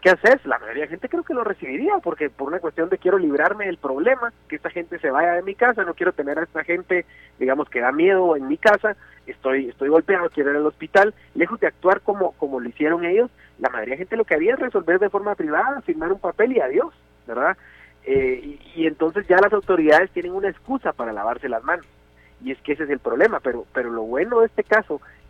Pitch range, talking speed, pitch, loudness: 155-225 Hz, 240 wpm, 180 Hz, -21 LUFS